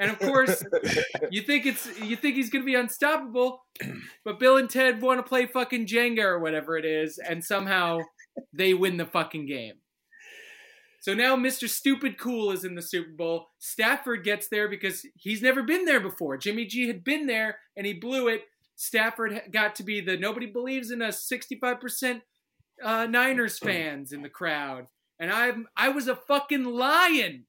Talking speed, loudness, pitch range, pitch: 185 wpm, -26 LUFS, 190-260 Hz, 235 Hz